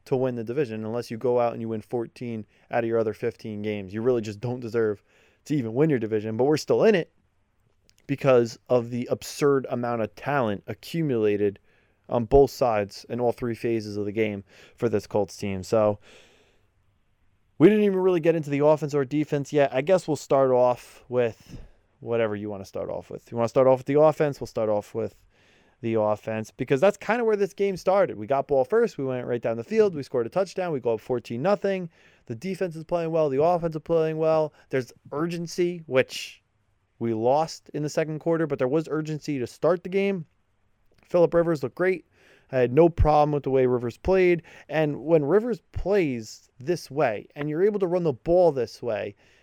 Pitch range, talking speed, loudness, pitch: 110-160 Hz, 210 wpm, -25 LUFS, 130 Hz